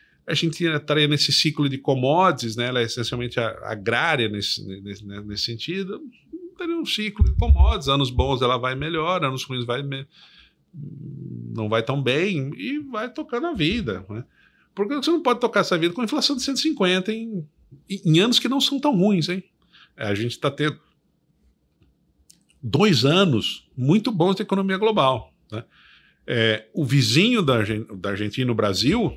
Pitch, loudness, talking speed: 150 Hz, -22 LUFS, 165 wpm